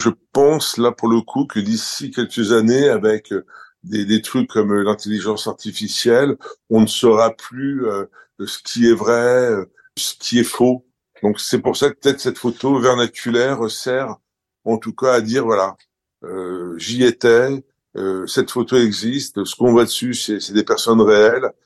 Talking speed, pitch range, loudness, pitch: 170 wpm, 110-130 Hz, -17 LUFS, 120 Hz